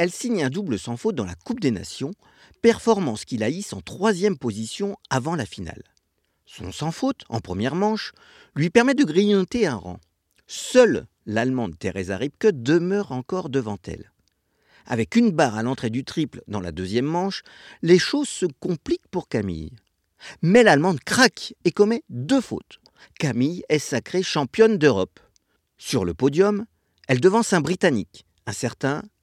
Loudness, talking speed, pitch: -22 LUFS, 160 wpm, 160 Hz